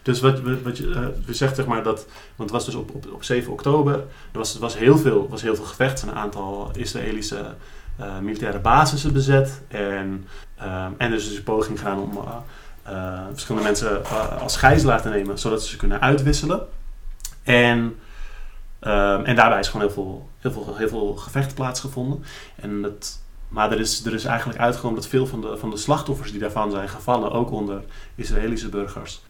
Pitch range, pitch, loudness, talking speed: 100-130 Hz, 110 Hz, -22 LUFS, 195 wpm